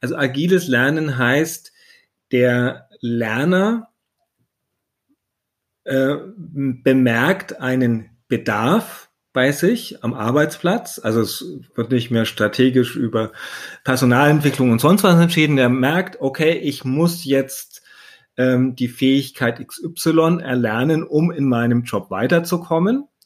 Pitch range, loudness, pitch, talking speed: 125-165 Hz, -18 LUFS, 135 Hz, 110 wpm